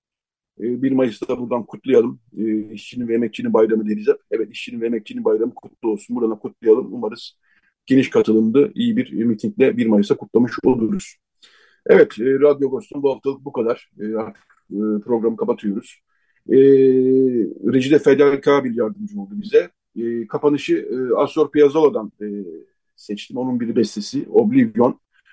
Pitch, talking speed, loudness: 135 Hz, 130 wpm, -18 LUFS